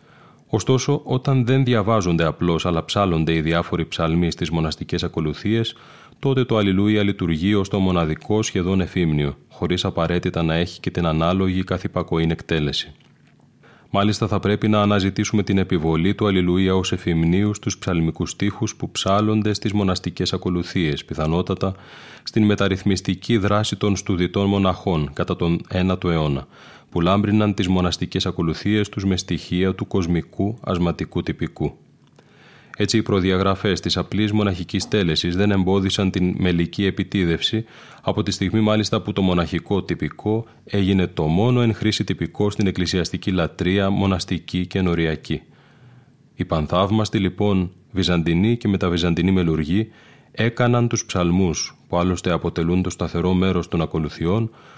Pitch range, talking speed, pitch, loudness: 85-105 Hz, 135 wpm, 95 Hz, -21 LUFS